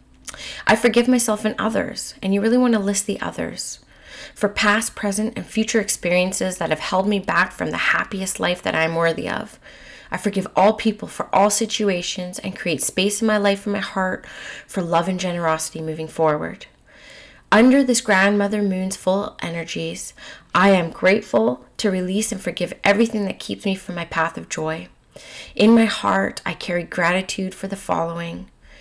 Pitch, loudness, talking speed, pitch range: 195 Hz, -20 LUFS, 180 wpm, 175-210 Hz